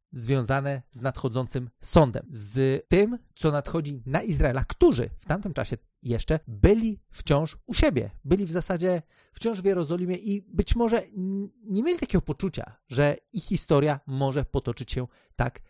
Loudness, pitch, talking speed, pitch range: -27 LUFS, 155 Hz, 155 wpm, 135-190 Hz